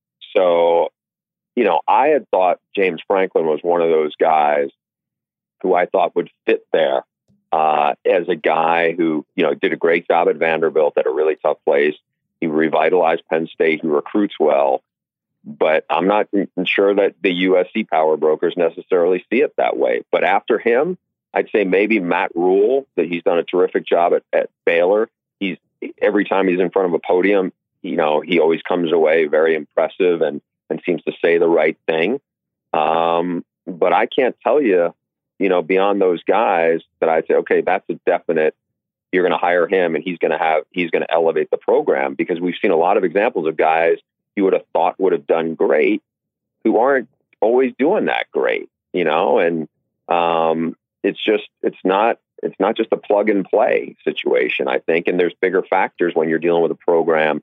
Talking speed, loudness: 195 wpm, -17 LUFS